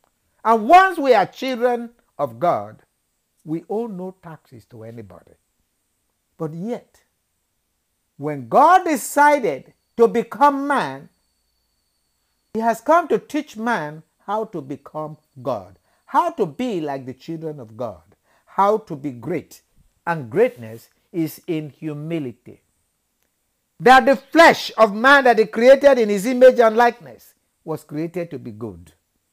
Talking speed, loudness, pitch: 135 wpm, -18 LUFS, 165 Hz